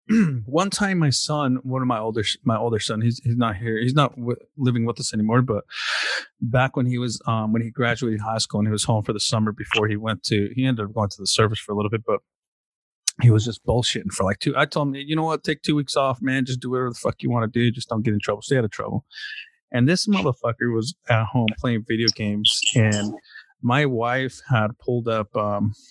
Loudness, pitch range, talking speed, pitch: -22 LUFS, 110-130 Hz, 250 wpm, 120 Hz